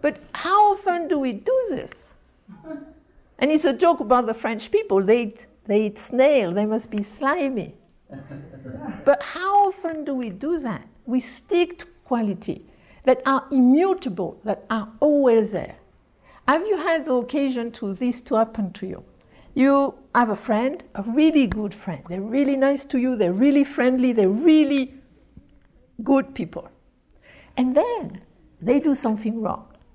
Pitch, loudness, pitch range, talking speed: 255 Hz, -22 LUFS, 220-295 Hz, 155 wpm